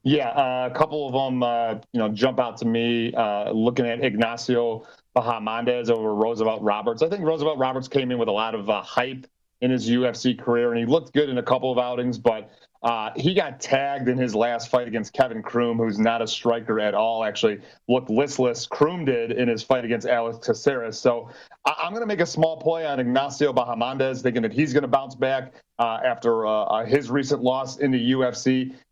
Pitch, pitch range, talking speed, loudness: 125 Hz, 115-135 Hz, 215 wpm, -23 LUFS